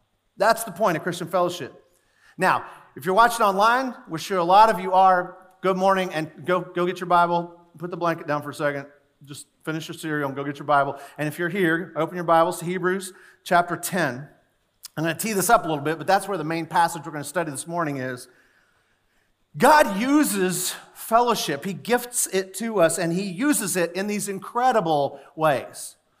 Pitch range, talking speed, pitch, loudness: 160-195 Hz, 210 wpm, 175 Hz, -22 LUFS